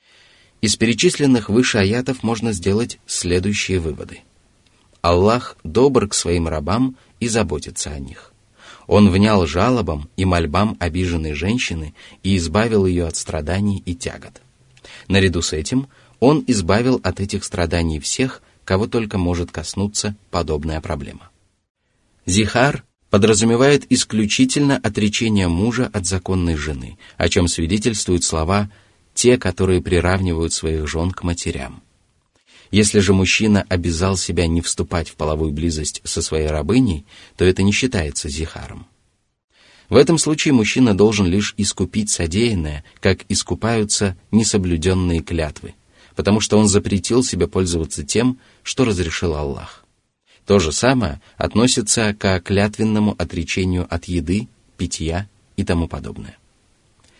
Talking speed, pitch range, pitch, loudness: 125 wpm, 85-110 Hz, 95 Hz, -18 LUFS